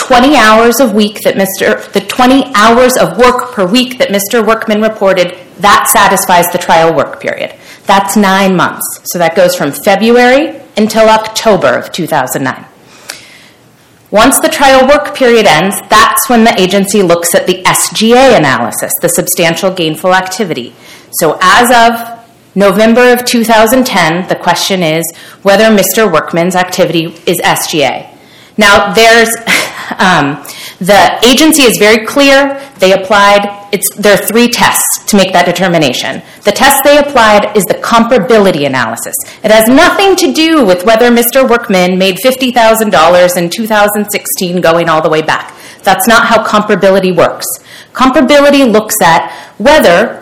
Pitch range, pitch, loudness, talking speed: 185-245 Hz, 210 Hz, -7 LUFS, 155 wpm